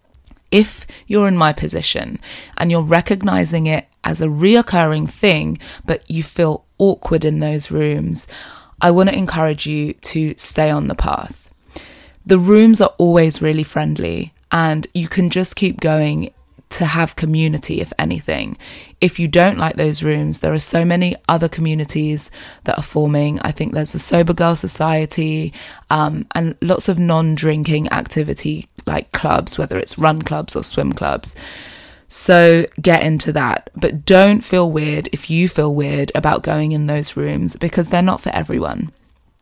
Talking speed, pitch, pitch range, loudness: 165 wpm, 155 Hz, 150-175 Hz, -16 LUFS